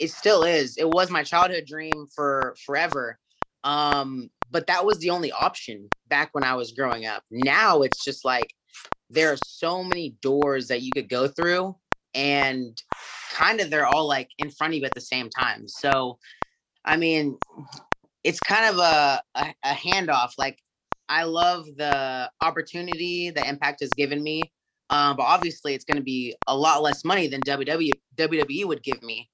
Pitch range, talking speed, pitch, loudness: 135-165 Hz, 180 wpm, 145 Hz, -24 LUFS